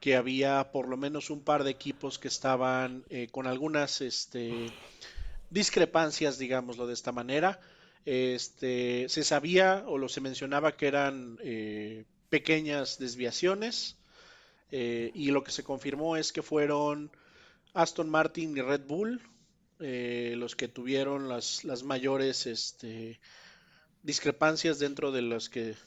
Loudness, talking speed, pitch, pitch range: -31 LUFS, 135 wpm, 135 Hz, 125-155 Hz